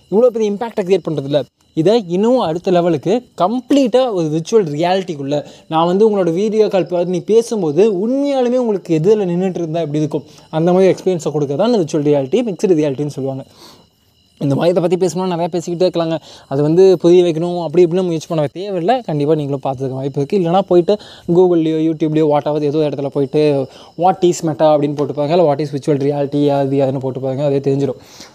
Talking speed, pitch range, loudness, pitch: 180 wpm, 145-185 Hz, -15 LUFS, 165 Hz